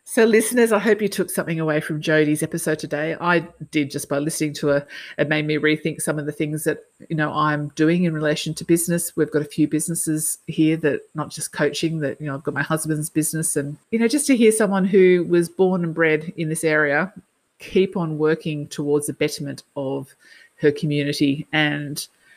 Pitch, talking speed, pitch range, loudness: 155 Hz, 210 wpm, 150-170 Hz, -21 LUFS